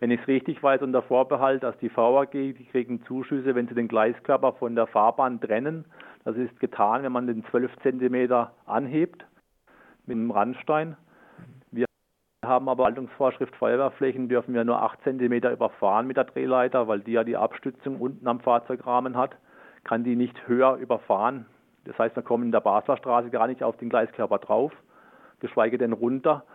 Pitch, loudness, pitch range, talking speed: 125 Hz, -25 LUFS, 120-130 Hz, 175 wpm